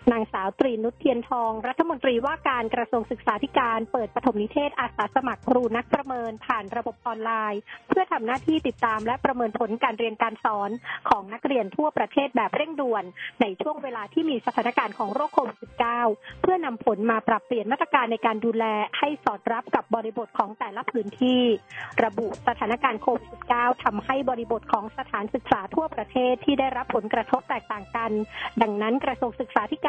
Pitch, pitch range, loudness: 245 Hz, 225-270 Hz, -26 LUFS